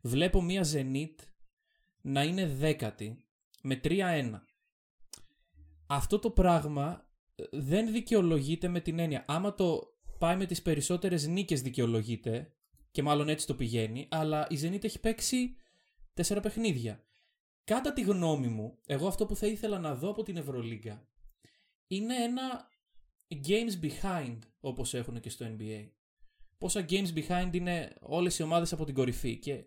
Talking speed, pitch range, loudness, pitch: 140 wpm, 130-195 Hz, -33 LUFS, 160 Hz